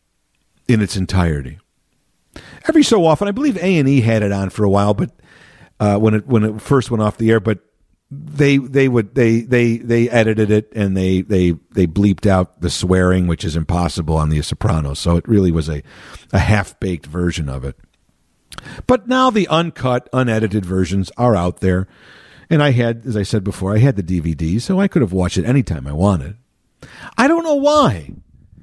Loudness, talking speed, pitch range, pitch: -16 LUFS, 195 wpm, 90-125 Hz, 105 Hz